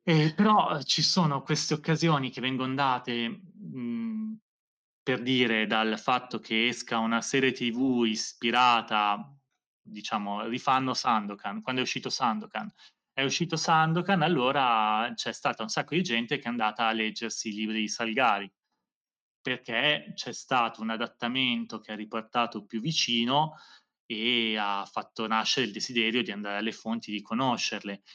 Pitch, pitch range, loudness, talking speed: 120 Hz, 110-150 Hz, -28 LUFS, 145 wpm